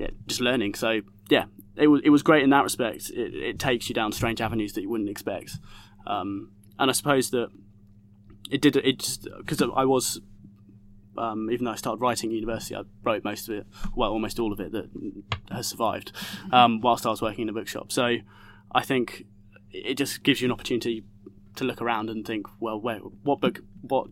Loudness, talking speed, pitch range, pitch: -26 LUFS, 210 wpm, 100-125 Hz, 110 Hz